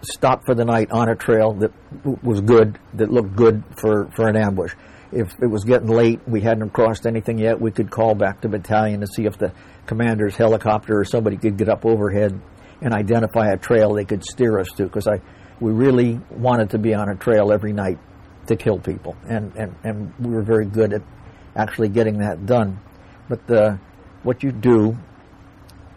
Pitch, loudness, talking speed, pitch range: 110 Hz, -19 LUFS, 195 wpm, 105-115 Hz